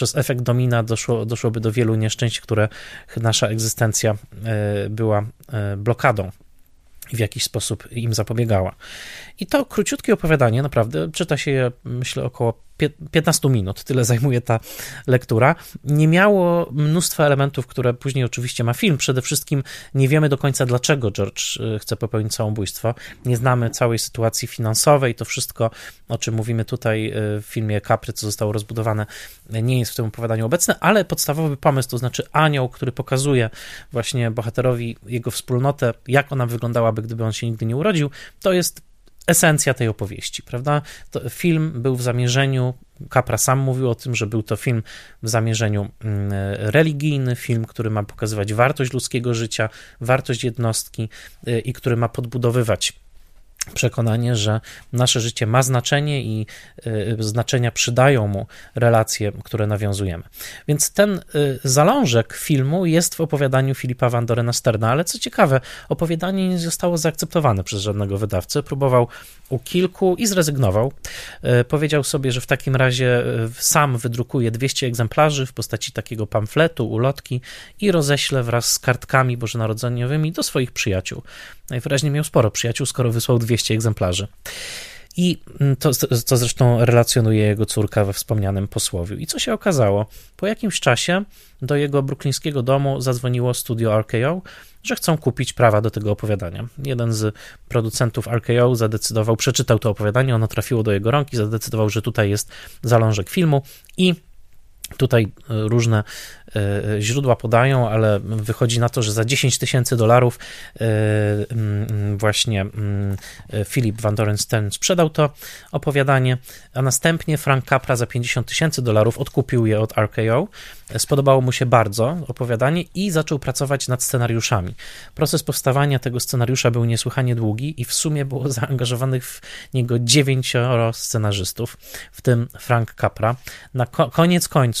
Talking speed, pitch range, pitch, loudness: 145 wpm, 110-140 Hz, 120 Hz, -20 LUFS